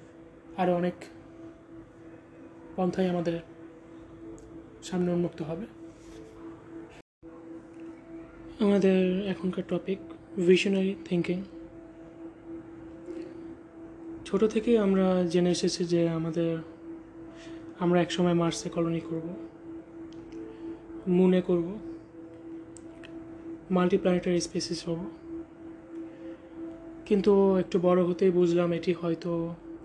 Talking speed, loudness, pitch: 70 wpm, -27 LUFS, 180 Hz